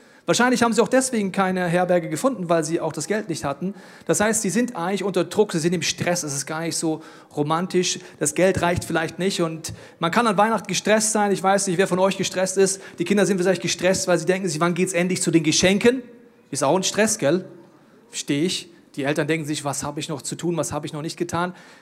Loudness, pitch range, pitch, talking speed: -22 LUFS, 165-195 Hz, 180 Hz, 250 wpm